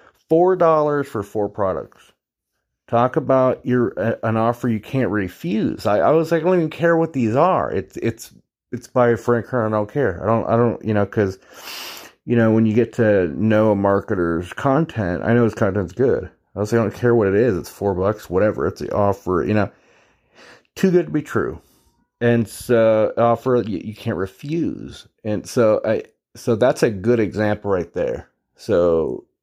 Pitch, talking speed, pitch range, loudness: 115 Hz, 200 wpm, 105-135 Hz, -19 LUFS